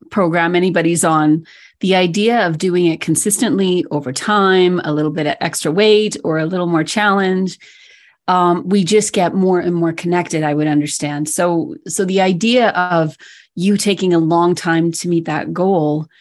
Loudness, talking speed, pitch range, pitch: -15 LUFS, 175 wpm, 165-195 Hz, 175 Hz